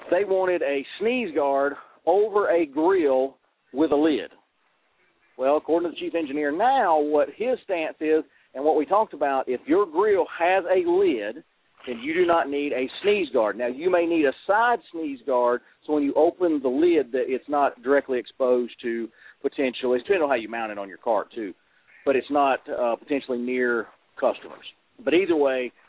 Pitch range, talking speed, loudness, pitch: 130-195 Hz, 190 wpm, -24 LUFS, 150 Hz